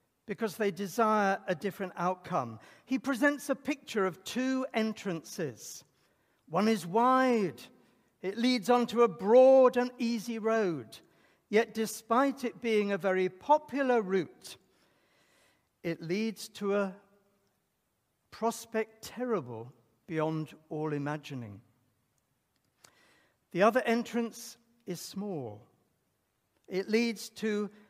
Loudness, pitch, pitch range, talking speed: -31 LUFS, 215 Hz, 180-235 Hz, 105 wpm